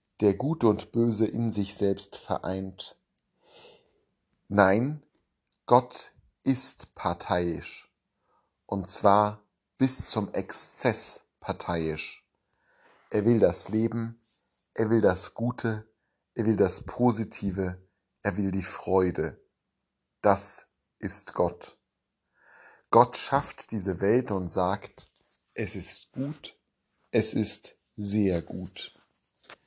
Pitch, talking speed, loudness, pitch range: 105 Hz, 100 wpm, -27 LUFS, 95-115 Hz